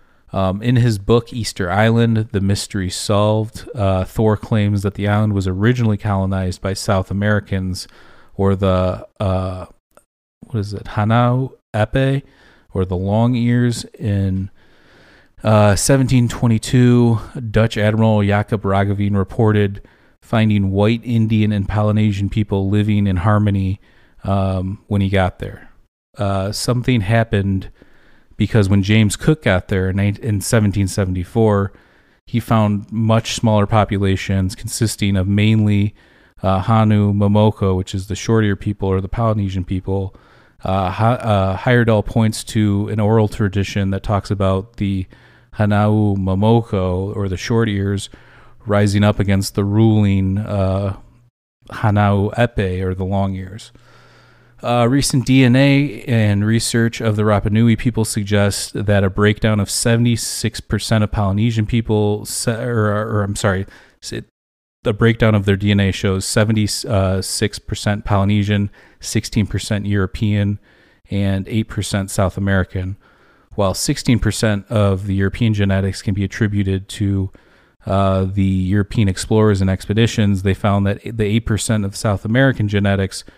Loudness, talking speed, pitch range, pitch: -17 LUFS, 130 wpm, 95-110 Hz, 105 Hz